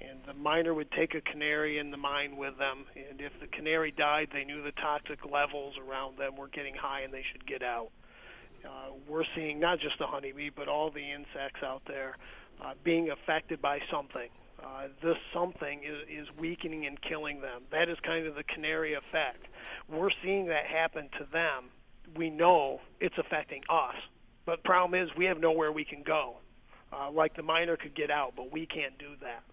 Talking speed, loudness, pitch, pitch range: 200 wpm, -33 LUFS, 150 Hz, 140-160 Hz